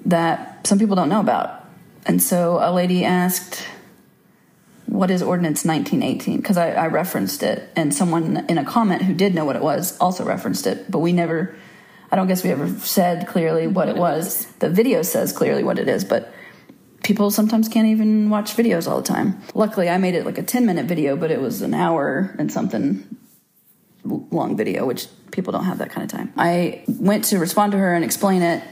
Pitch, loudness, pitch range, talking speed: 185 Hz, -20 LUFS, 170-215 Hz, 205 wpm